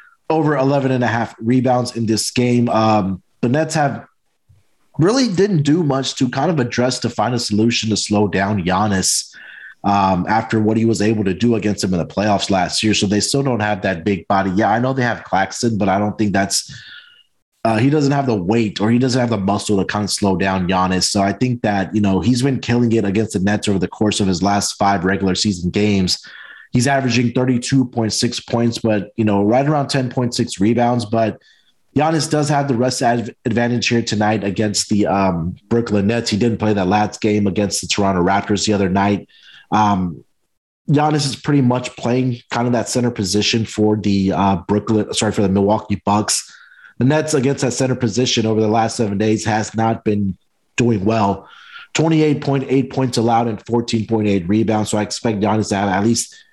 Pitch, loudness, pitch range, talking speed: 110 Hz, -17 LUFS, 100-125 Hz, 210 wpm